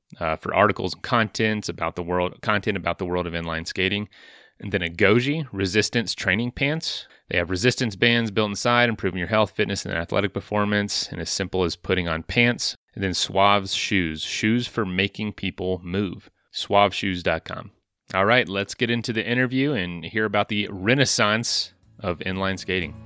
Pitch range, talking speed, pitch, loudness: 95-115 Hz, 175 wpm, 100 Hz, -23 LUFS